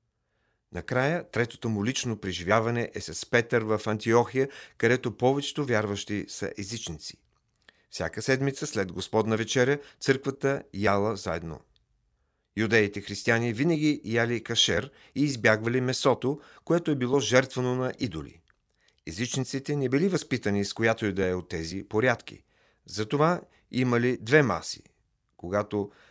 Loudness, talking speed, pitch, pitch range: -27 LUFS, 125 wpm, 115 Hz, 105-130 Hz